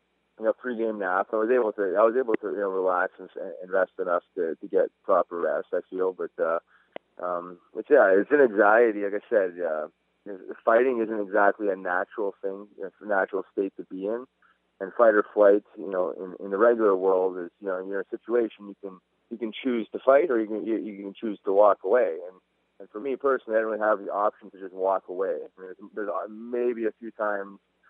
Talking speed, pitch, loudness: 230 wpm, 110 Hz, -25 LUFS